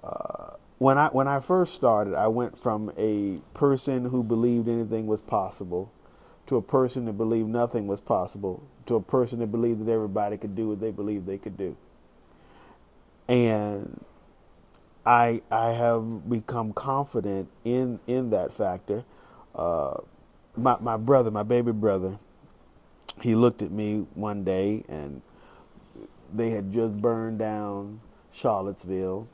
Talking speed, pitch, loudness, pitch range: 145 wpm, 110 Hz, -27 LUFS, 105-120 Hz